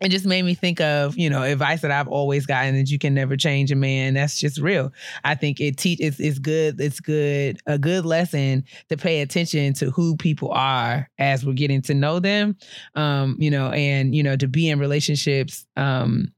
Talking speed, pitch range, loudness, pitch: 215 wpm, 140-160 Hz, -21 LUFS, 145 Hz